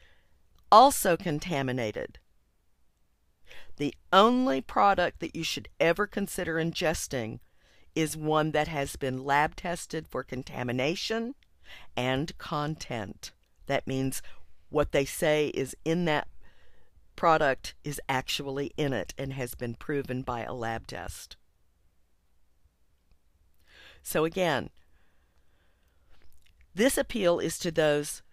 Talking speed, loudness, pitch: 105 wpm, -28 LUFS, 135 Hz